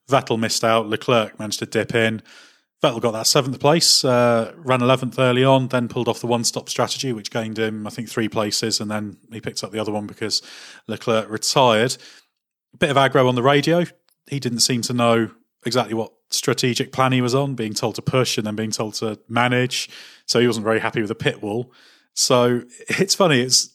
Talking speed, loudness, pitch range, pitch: 210 wpm, -20 LUFS, 110-130 Hz, 120 Hz